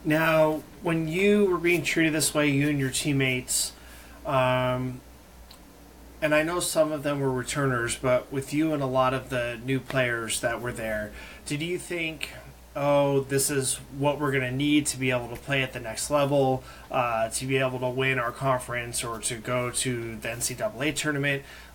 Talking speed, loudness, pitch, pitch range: 190 wpm, -26 LUFS, 135 Hz, 125-150 Hz